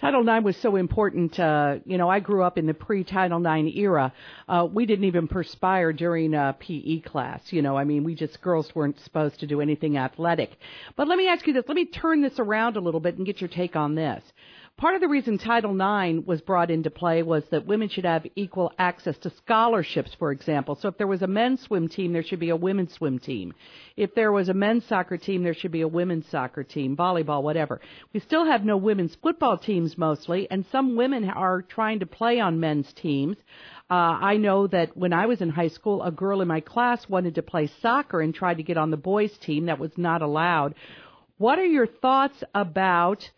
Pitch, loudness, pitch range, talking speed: 180 Hz, -25 LUFS, 160-205 Hz, 225 wpm